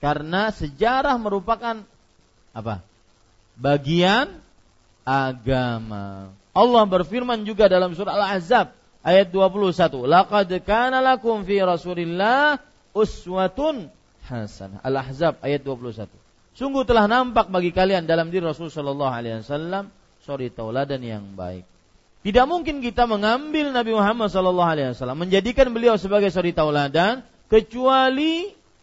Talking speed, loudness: 110 wpm, -21 LUFS